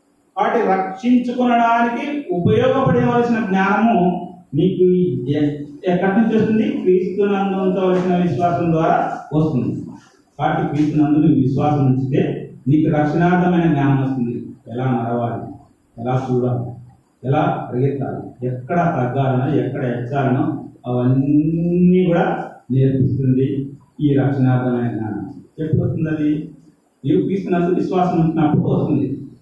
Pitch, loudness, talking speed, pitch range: 150 Hz, -18 LUFS, 90 wpm, 135-180 Hz